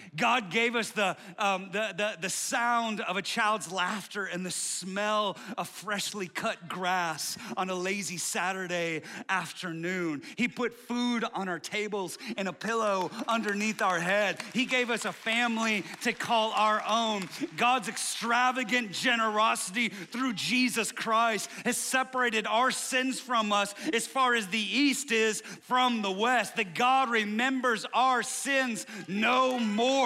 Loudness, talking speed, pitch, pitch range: -29 LUFS, 150 wpm, 220 Hz, 195-240 Hz